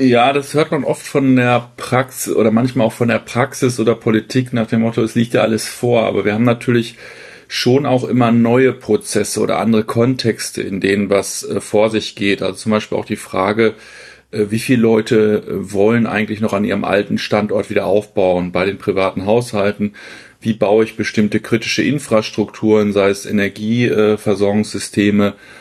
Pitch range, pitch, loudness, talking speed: 105-120 Hz, 110 Hz, -16 LUFS, 170 wpm